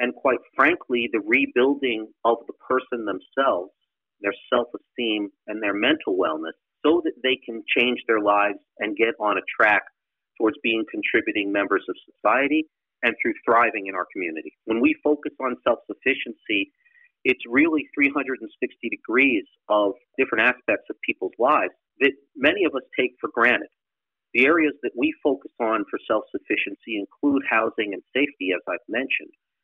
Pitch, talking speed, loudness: 135 Hz, 160 wpm, -23 LUFS